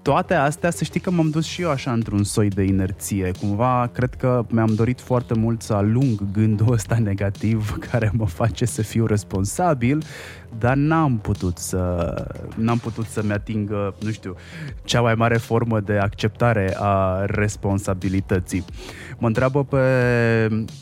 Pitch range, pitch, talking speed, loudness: 100-125 Hz, 110 Hz, 155 wpm, -21 LUFS